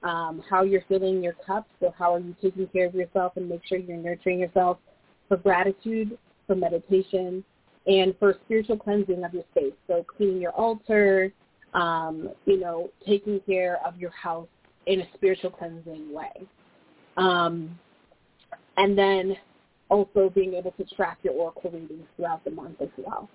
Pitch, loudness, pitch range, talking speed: 185 Hz, -26 LUFS, 175-195 Hz, 165 wpm